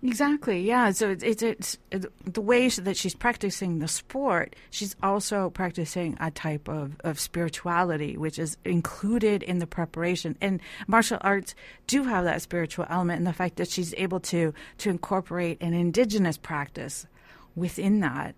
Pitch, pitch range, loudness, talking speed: 180 Hz, 170-205 Hz, -27 LUFS, 160 wpm